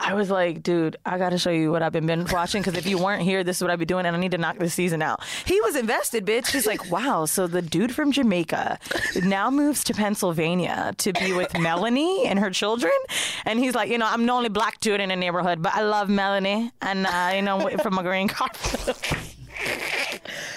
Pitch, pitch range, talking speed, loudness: 190 Hz, 175-220 Hz, 230 wpm, -23 LUFS